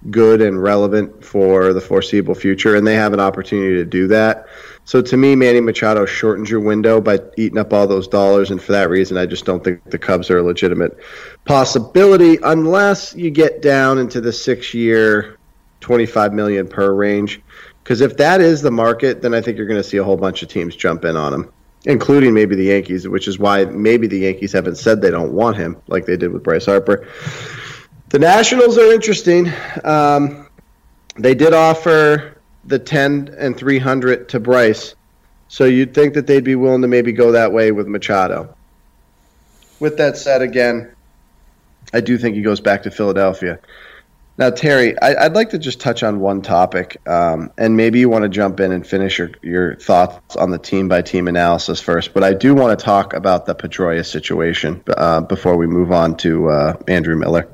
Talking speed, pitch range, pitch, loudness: 195 wpm, 95-130 Hz, 105 Hz, -14 LUFS